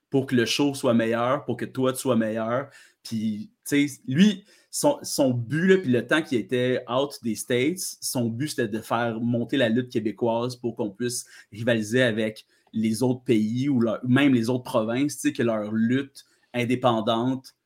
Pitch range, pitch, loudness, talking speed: 115-135 Hz, 125 Hz, -25 LUFS, 195 wpm